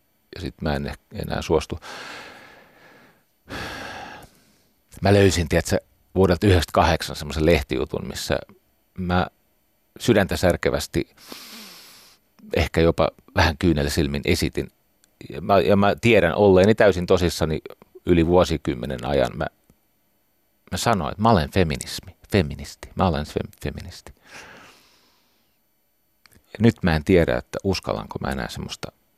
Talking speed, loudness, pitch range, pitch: 115 wpm, -21 LUFS, 75-95 Hz, 85 Hz